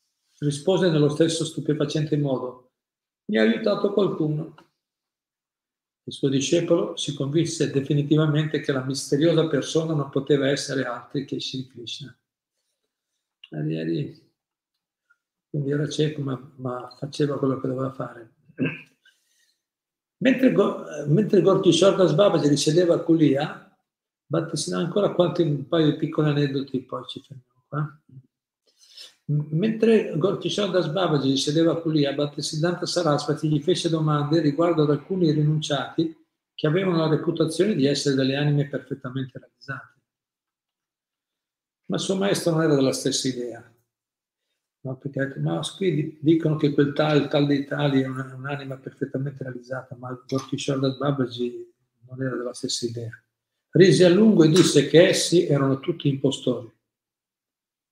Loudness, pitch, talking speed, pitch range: -23 LUFS, 150 Hz, 125 wpm, 135-165 Hz